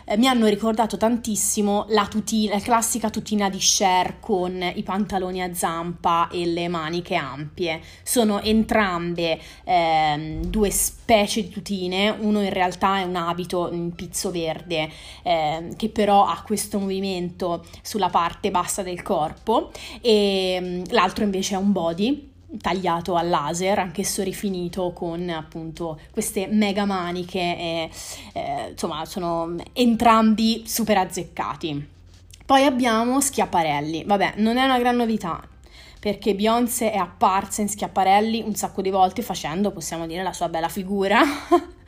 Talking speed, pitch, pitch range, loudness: 140 wpm, 195 Hz, 175-215 Hz, -22 LUFS